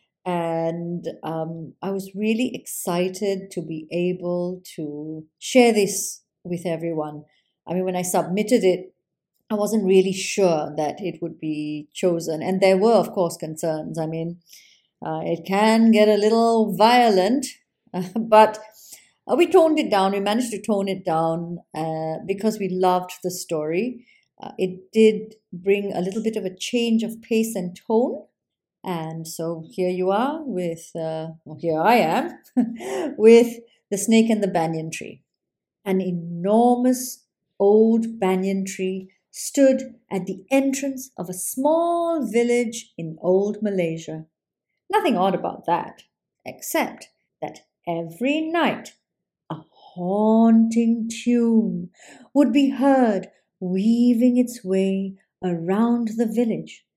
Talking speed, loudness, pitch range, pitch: 135 wpm, -22 LUFS, 175-225 Hz, 195 Hz